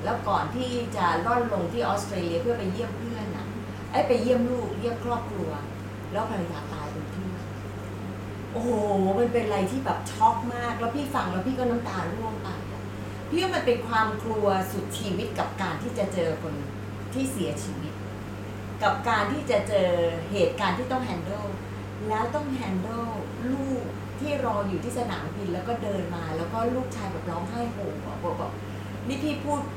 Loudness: -28 LUFS